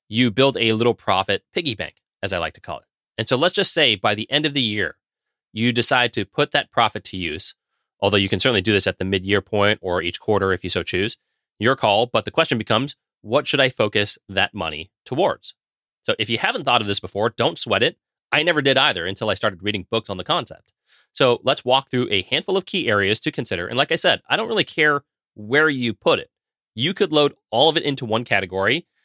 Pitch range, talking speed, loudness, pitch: 100-140 Hz, 245 wpm, -20 LUFS, 115 Hz